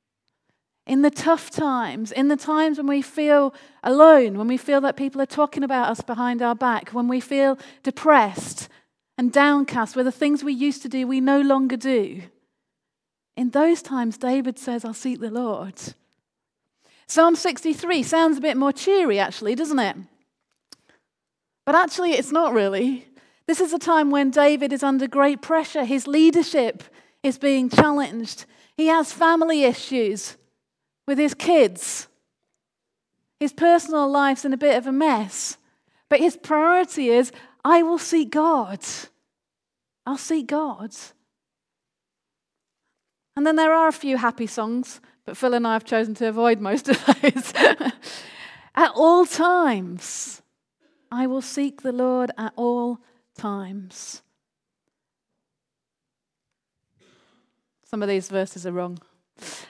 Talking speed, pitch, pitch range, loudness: 145 wpm, 275 Hz, 245-305 Hz, -21 LUFS